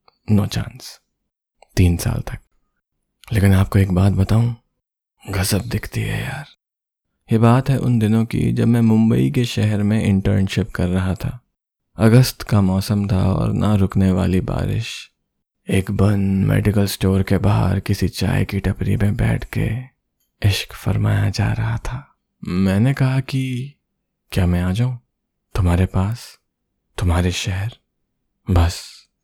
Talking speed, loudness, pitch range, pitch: 145 wpm, -19 LUFS, 95-120 Hz, 105 Hz